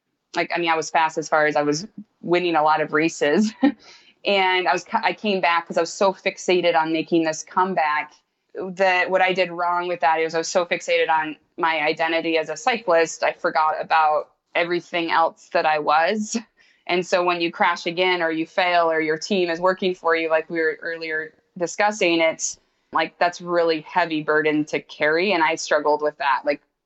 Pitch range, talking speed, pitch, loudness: 160-180 Hz, 205 wpm, 165 Hz, -21 LUFS